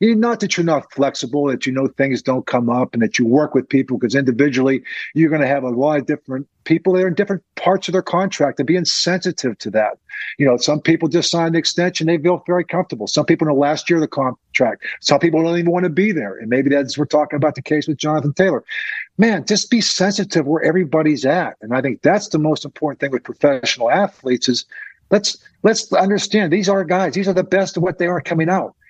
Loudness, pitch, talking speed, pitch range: -17 LUFS, 155 Hz, 240 wpm, 135-180 Hz